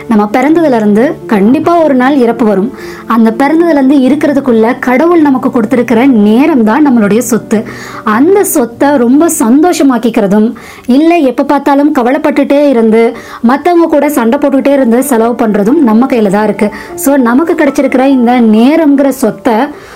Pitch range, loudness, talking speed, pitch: 230-290 Hz, -7 LUFS, 135 wpm, 260 Hz